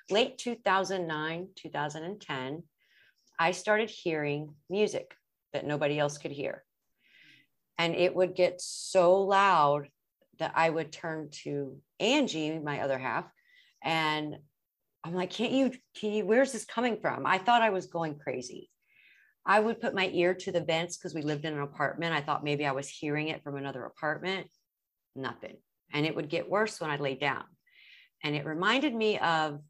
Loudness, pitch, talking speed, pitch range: -30 LUFS, 170 Hz, 170 wpm, 150-195 Hz